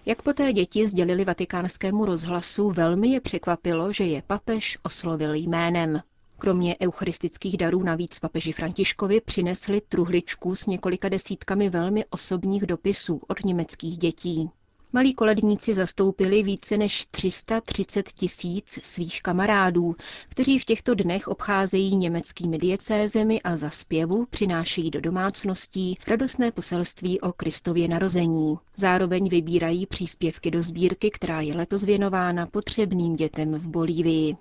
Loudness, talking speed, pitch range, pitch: -25 LUFS, 125 wpm, 170-200 Hz, 185 Hz